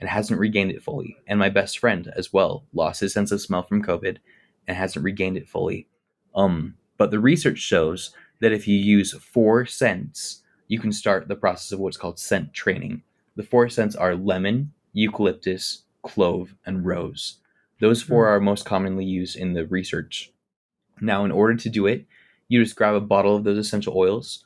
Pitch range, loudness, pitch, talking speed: 95-110 Hz, -22 LUFS, 100 Hz, 190 wpm